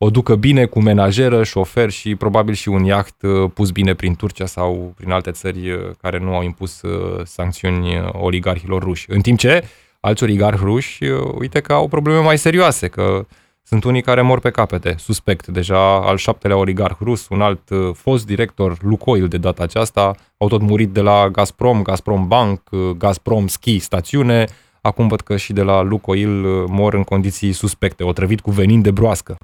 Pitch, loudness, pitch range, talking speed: 100 Hz, -16 LUFS, 95-110 Hz, 175 wpm